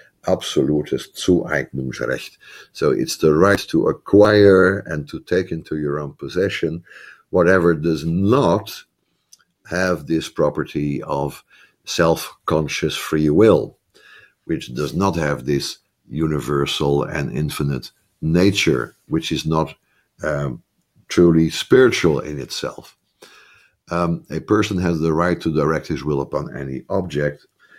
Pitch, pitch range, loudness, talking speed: 80 Hz, 75-85 Hz, -19 LUFS, 120 wpm